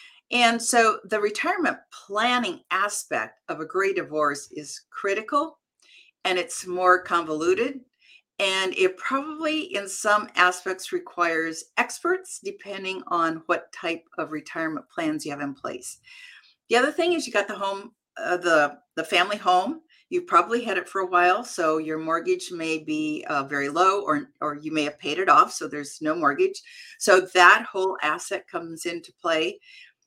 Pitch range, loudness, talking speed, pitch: 165-270 Hz, -24 LUFS, 165 wpm, 190 Hz